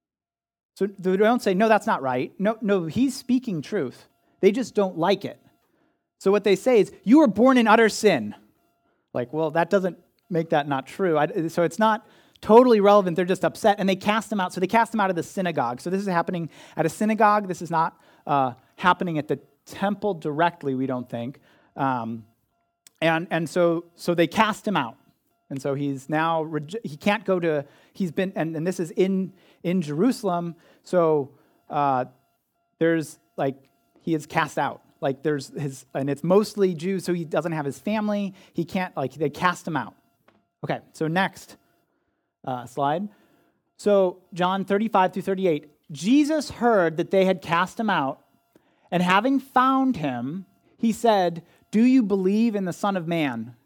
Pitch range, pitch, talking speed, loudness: 150-205 Hz, 180 Hz, 180 wpm, -23 LUFS